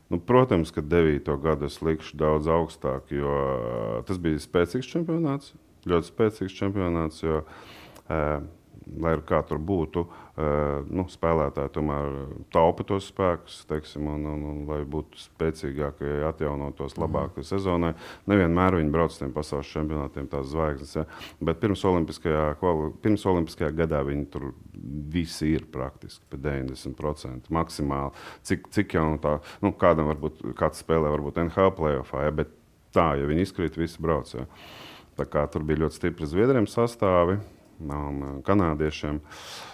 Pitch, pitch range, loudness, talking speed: 80 Hz, 75-85 Hz, -27 LUFS, 145 wpm